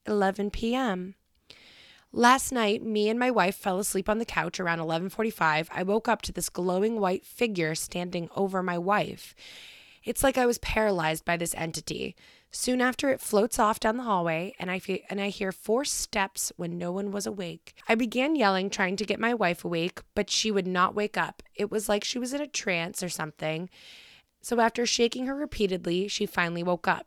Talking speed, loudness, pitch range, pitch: 200 wpm, -28 LUFS, 175-225 Hz, 200 Hz